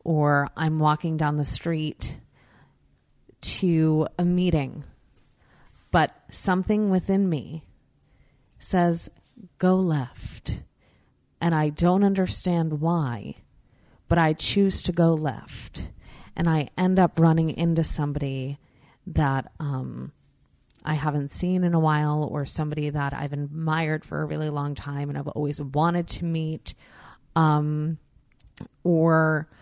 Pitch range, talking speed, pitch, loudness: 145-170 Hz, 120 wpm, 155 Hz, -25 LUFS